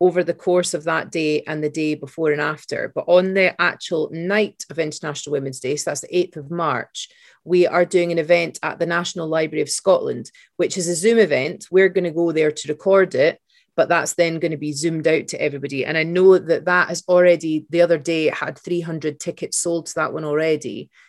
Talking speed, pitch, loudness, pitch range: 230 wpm, 170 Hz, -20 LUFS, 155-180 Hz